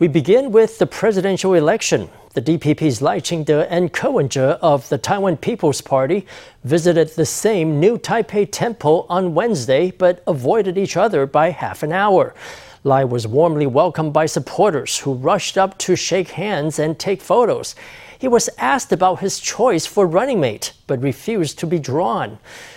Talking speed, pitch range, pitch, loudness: 165 wpm, 155-200 Hz, 175 Hz, -17 LUFS